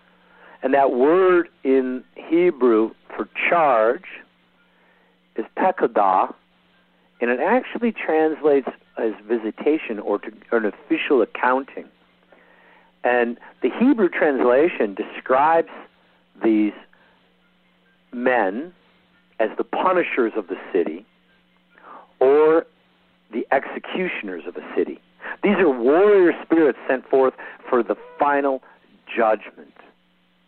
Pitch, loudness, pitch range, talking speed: 135 Hz, -20 LUFS, 110-175 Hz, 95 wpm